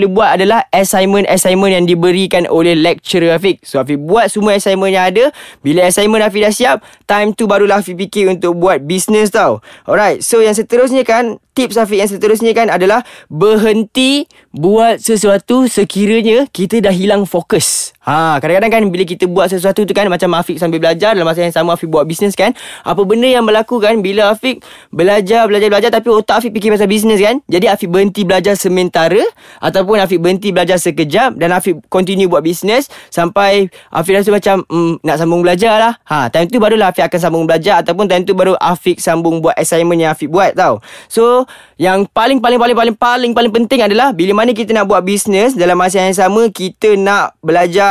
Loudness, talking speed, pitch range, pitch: -11 LUFS, 195 wpm, 180-220 Hz, 200 Hz